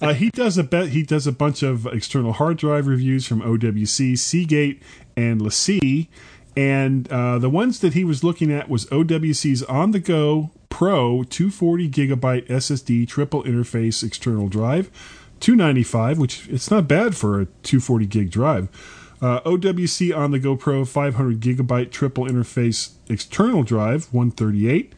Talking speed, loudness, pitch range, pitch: 155 wpm, -20 LUFS, 120-155 Hz, 135 Hz